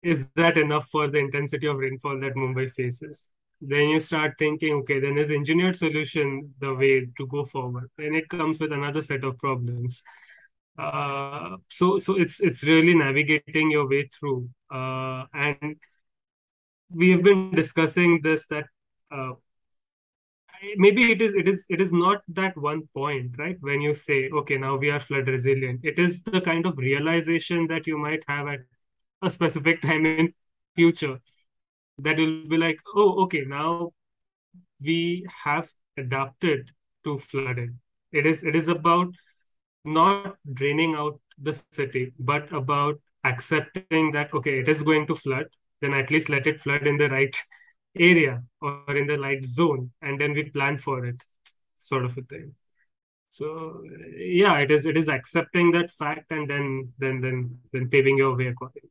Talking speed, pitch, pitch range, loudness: 165 wpm, 150 Hz, 135-165 Hz, -24 LUFS